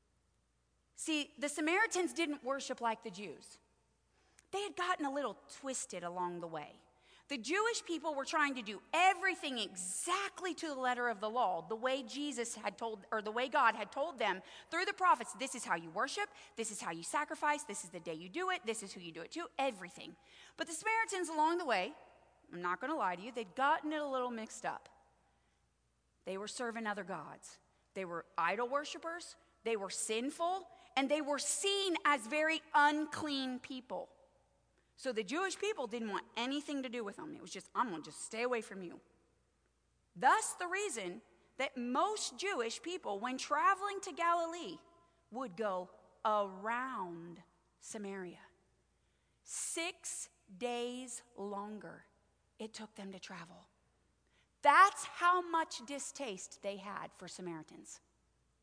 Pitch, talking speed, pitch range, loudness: 265 Hz, 165 wpm, 215-330 Hz, -37 LUFS